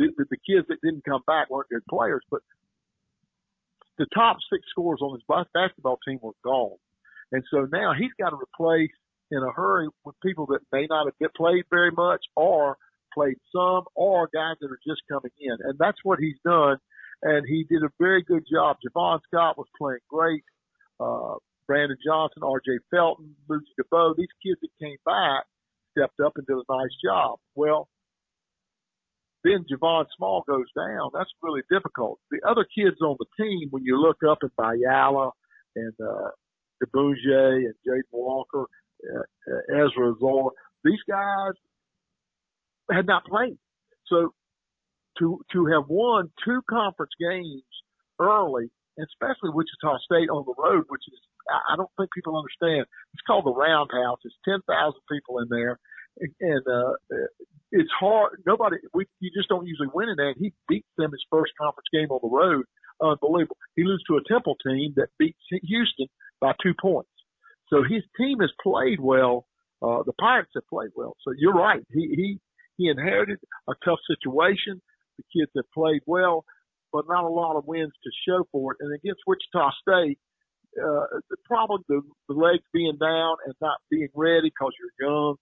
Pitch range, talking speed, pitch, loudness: 140-190 Hz, 175 wpm, 160 Hz, -25 LUFS